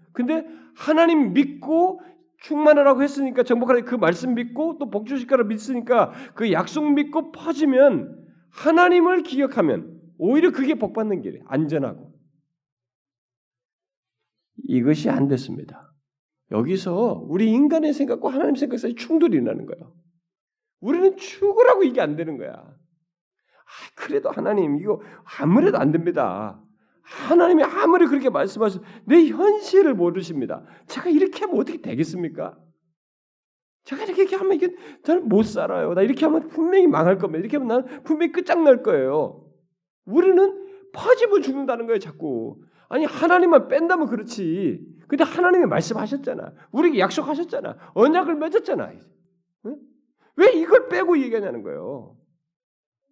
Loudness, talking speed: -20 LUFS, 330 characters per minute